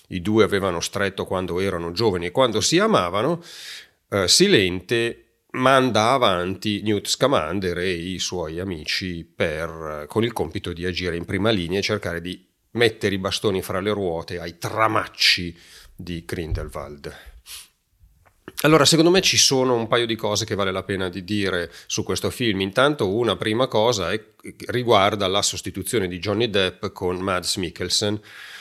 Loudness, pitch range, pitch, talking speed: -21 LUFS, 90-110 Hz, 100 Hz, 160 wpm